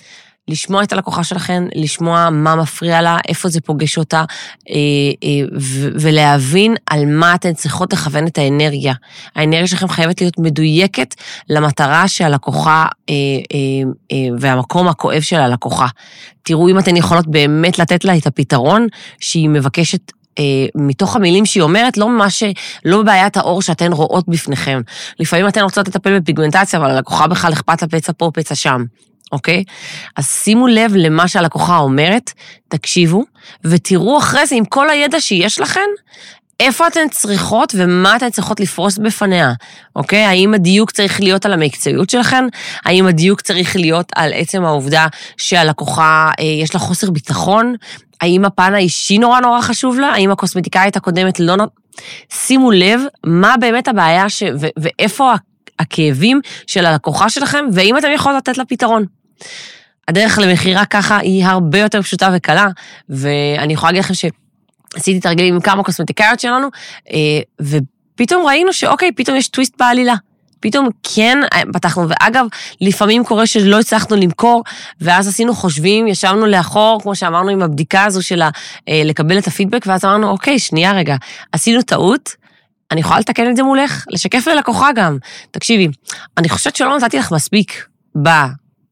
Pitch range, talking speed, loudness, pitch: 160-210 Hz, 145 wpm, -12 LUFS, 185 Hz